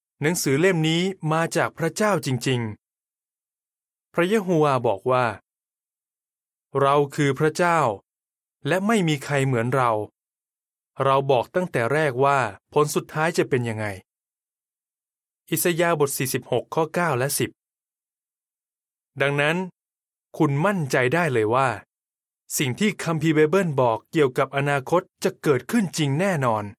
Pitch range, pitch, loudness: 135-170 Hz, 150 Hz, -22 LUFS